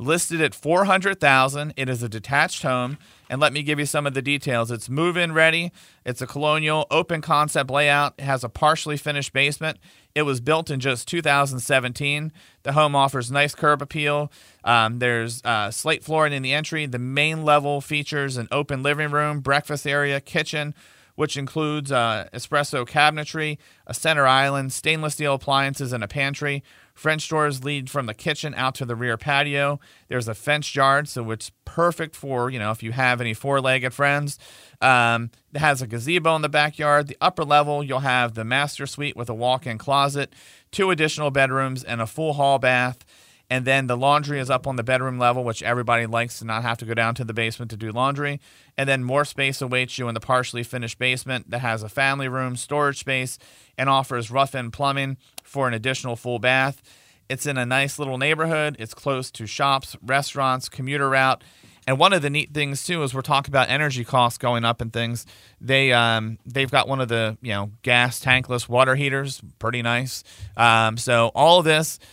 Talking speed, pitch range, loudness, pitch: 195 wpm, 125-145 Hz, -22 LUFS, 135 Hz